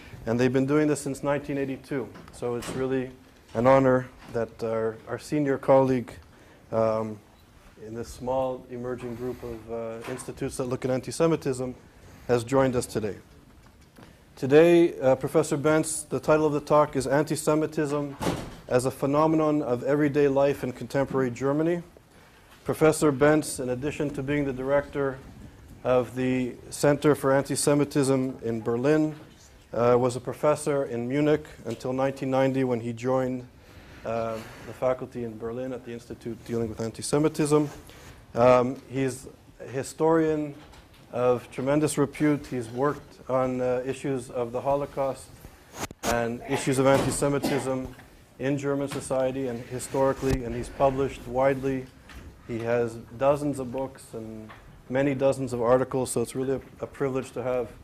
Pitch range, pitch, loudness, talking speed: 120-140 Hz, 130 Hz, -26 LUFS, 140 wpm